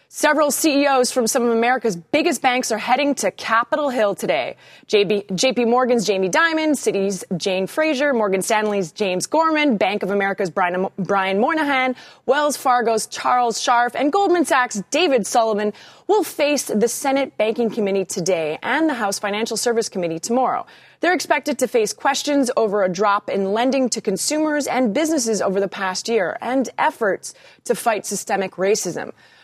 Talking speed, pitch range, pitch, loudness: 155 wpm, 200-275 Hz, 235 Hz, -19 LUFS